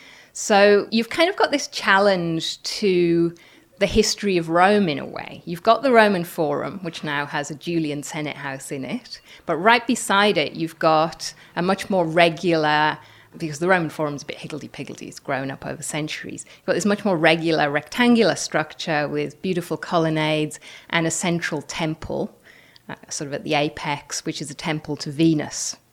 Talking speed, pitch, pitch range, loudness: 185 wpm, 165 Hz, 150-195 Hz, -21 LUFS